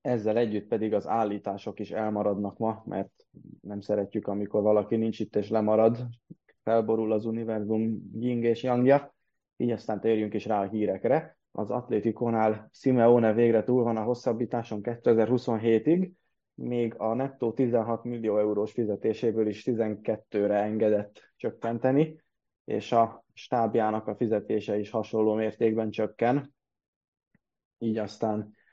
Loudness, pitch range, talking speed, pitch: -28 LUFS, 105-120 Hz, 125 wpm, 110 Hz